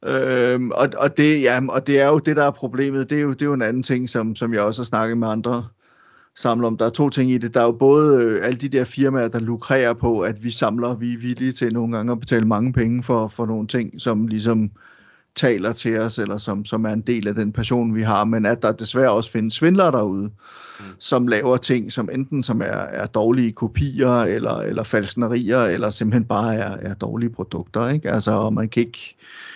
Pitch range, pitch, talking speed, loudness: 110-125 Hz, 120 Hz, 240 wpm, -20 LUFS